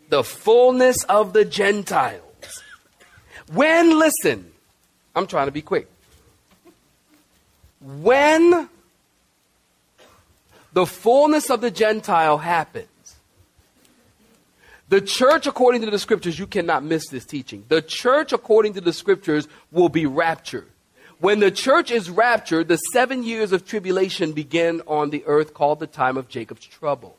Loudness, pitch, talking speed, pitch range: -19 LUFS, 180 Hz, 130 wpm, 150-235 Hz